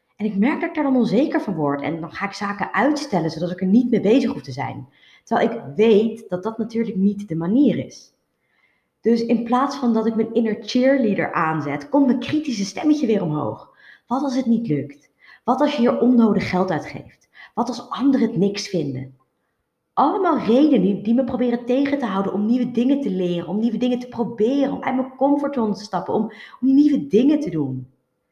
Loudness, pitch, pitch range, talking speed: -20 LUFS, 225 Hz, 185-255 Hz, 210 wpm